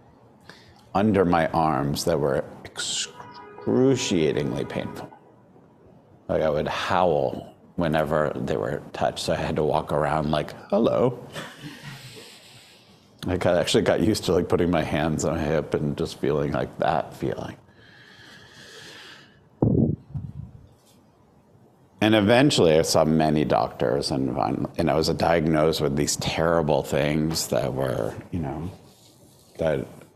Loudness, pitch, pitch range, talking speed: -24 LUFS, 80 Hz, 75-85 Hz, 120 wpm